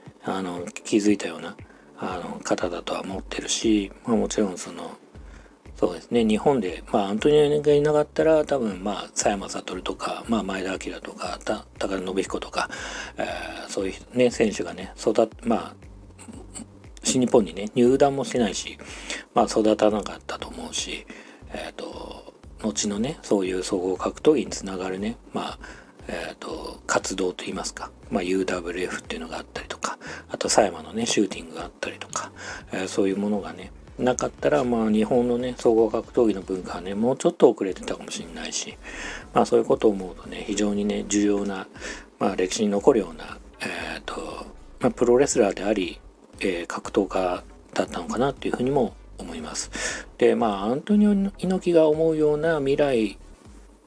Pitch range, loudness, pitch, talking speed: 95-140 Hz, -25 LUFS, 105 Hz, 350 characters per minute